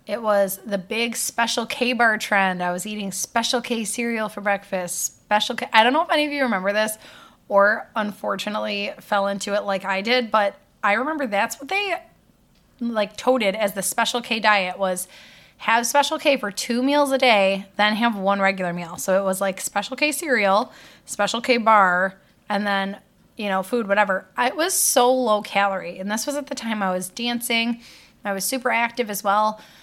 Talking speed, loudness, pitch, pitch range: 200 wpm, -21 LUFS, 215 Hz, 195-245 Hz